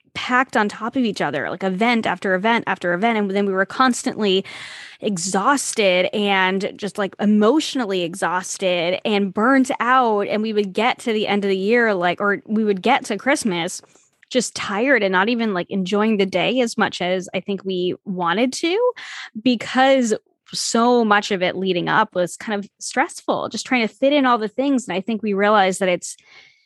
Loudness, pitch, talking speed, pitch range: -19 LUFS, 210 Hz, 195 wpm, 190-250 Hz